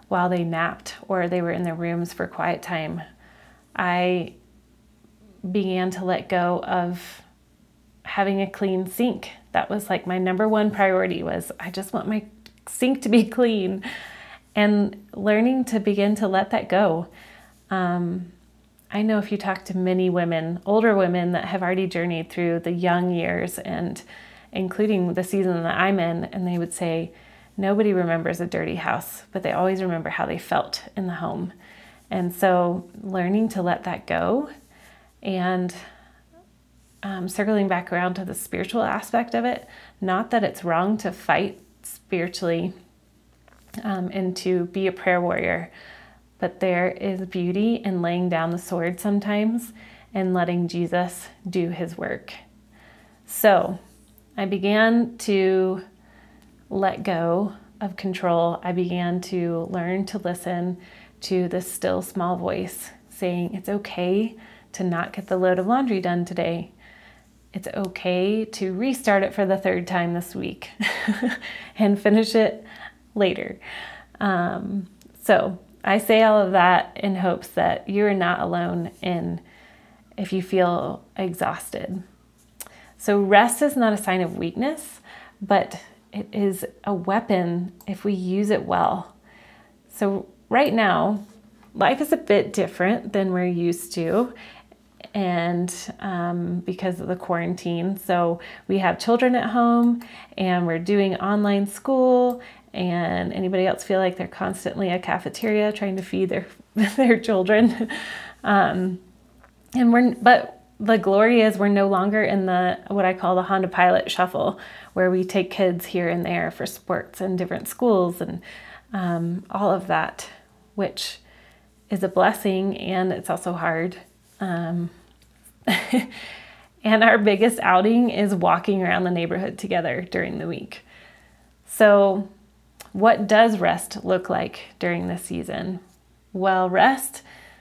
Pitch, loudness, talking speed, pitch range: 190 Hz, -23 LUFS, 145 wpm, 180-210 Hz